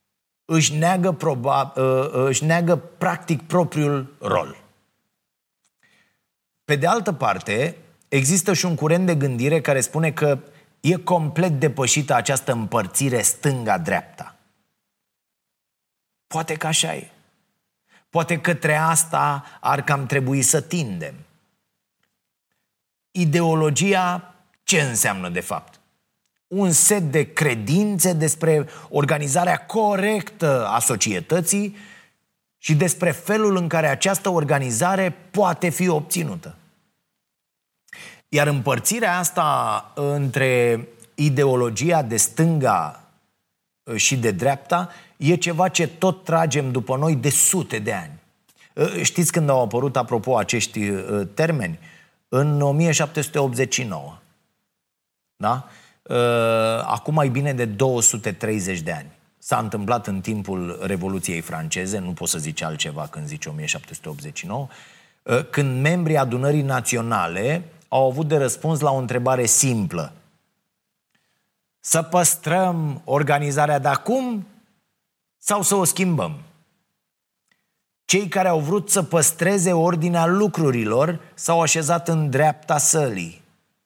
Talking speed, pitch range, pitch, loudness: 105 wpm, 130-175 Hz, 155 Hz, -20 LUFS